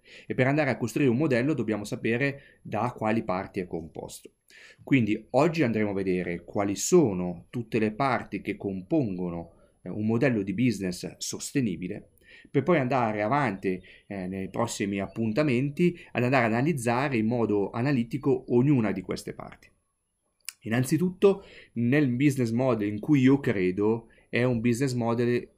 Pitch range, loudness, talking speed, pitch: 100-135 Hz, -27 LUFS, 145 wpm, 115 Hz